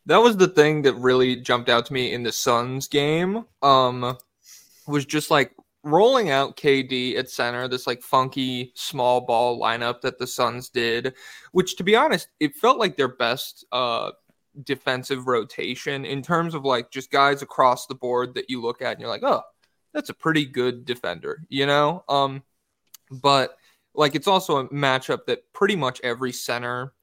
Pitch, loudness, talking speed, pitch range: 135 Hz, -22 LUFS, 180 wpm, 125-150 Hz